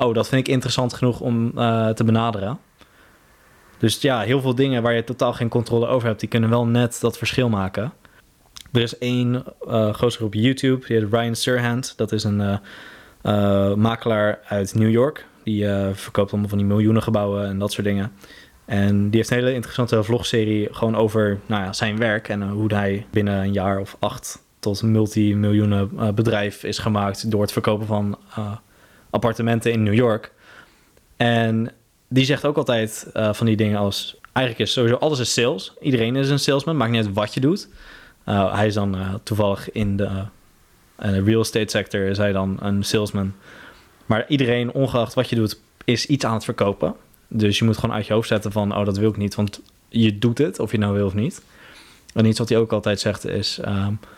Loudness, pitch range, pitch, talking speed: -21 LUFS, 105-120 Hz, 110 Hz, 205 wpm